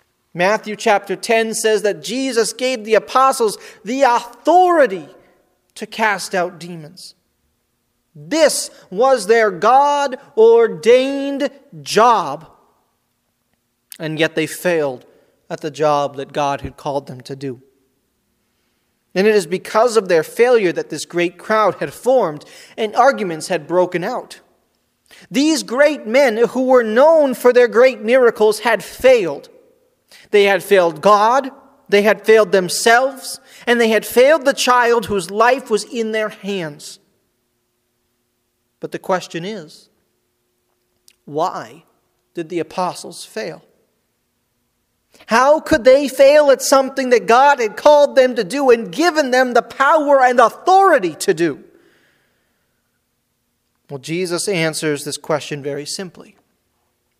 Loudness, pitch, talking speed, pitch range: -15 LUFS, 220 Hz, 130 wpm, 175-270 Hz